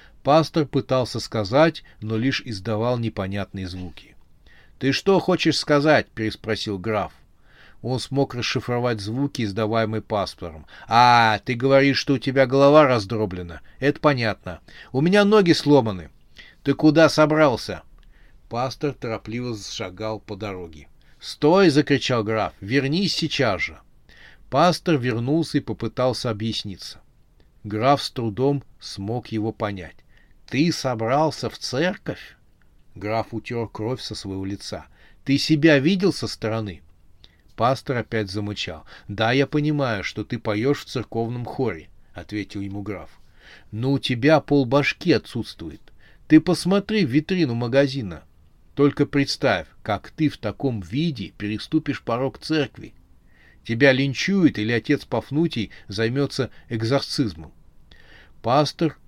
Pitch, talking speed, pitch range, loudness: 115 Hz, 120 wpm, 105-140 Hz, -22 LUFS